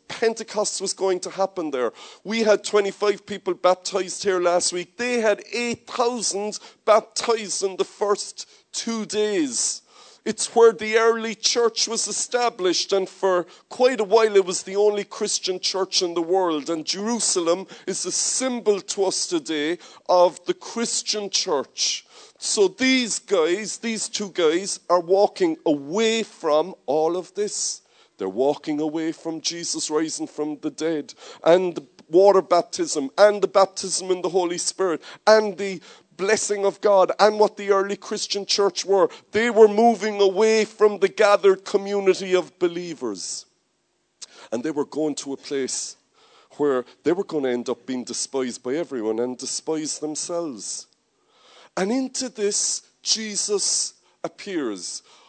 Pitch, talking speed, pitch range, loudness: 195 Hz, 150 wpm, 175-220 Hz, -22 LUFS